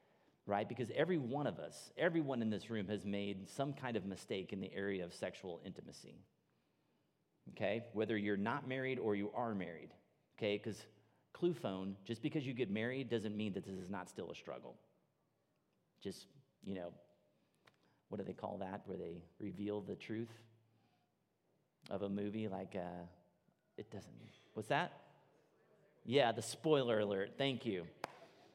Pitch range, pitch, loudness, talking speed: 100-120 Hz, 105 Hz, -42 LUFS, 160 wpm